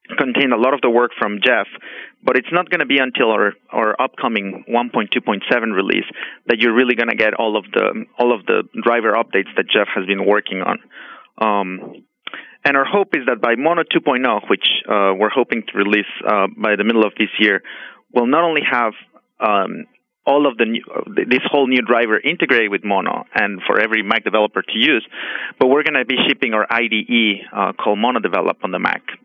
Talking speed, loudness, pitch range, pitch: 205 wpm, -17 LUFS, 105-120 Hz, 110 Hz